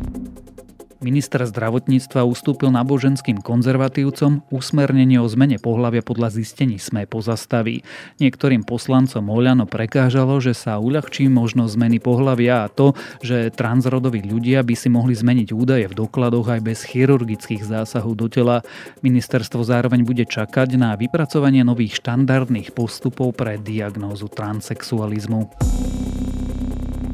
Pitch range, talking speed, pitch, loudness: 115-130 Hz, 115 wpm, 120 Hz, -19 LUFS